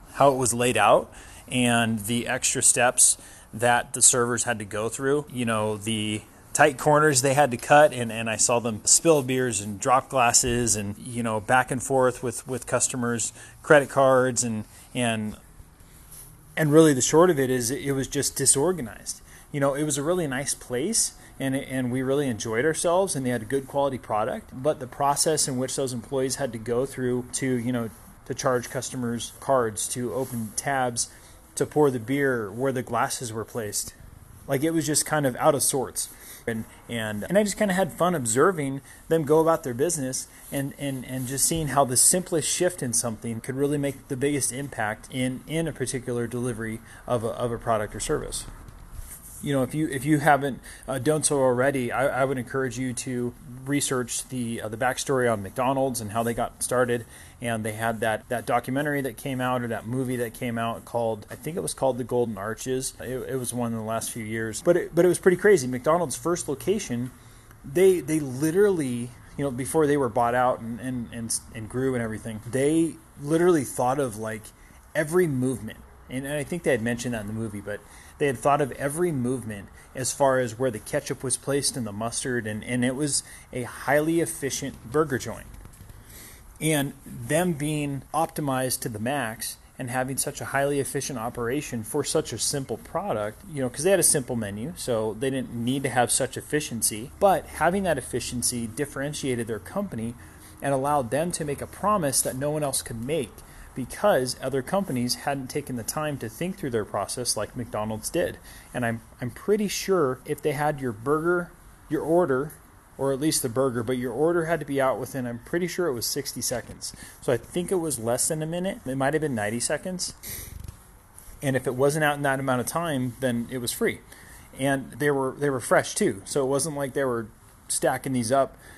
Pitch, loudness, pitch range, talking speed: 130 Hz, -25 LUFS, 115-145 Hz, 205 wpm